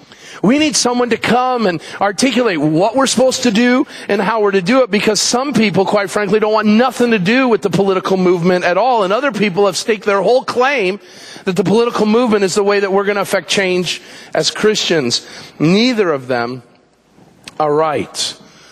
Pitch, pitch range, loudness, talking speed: 205 Hz, 190-240 Hz, -14 LUFS, 200 wpm